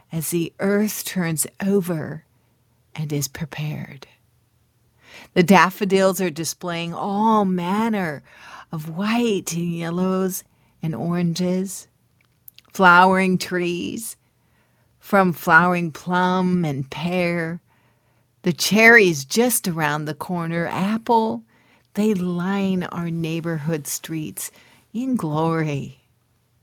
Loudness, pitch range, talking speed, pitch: -20 LUFS, 155-190 Hz, 90 wpm, 175 Hz